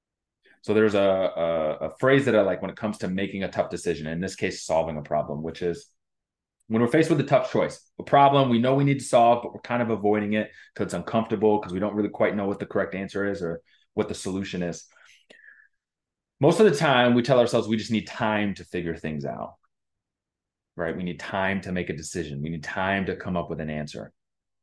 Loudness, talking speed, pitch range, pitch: -25 LUFS, 235 wpm, 85-115 Hz, 100 Hz